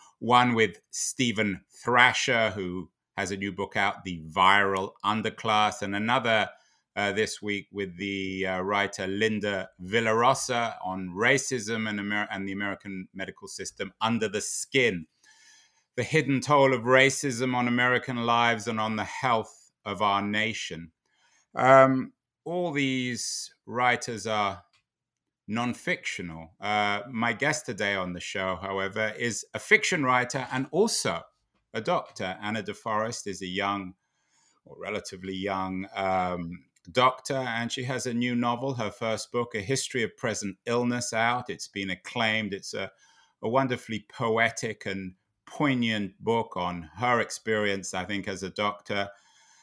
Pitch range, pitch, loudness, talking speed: 95-125 Hz, 110 Hz, -27 LUFS, 140 wpm